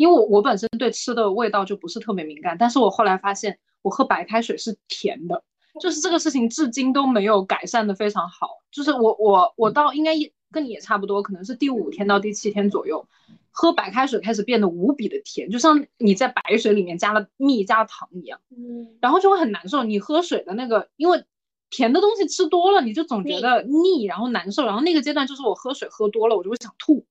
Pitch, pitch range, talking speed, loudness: 235 Hz, 210-305 Hz, 345 characters per minute, -21 LUFS